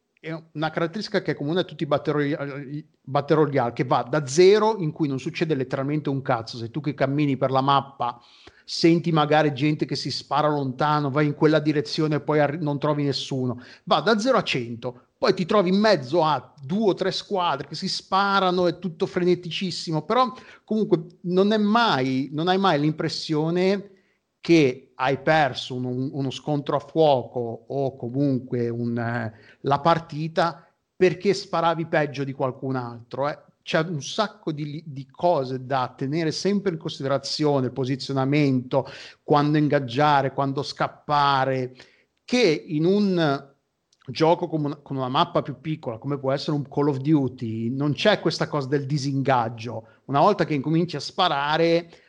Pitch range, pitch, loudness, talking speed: 135-170 Hz, 150 Hz, -23 LUFS, 165 wpm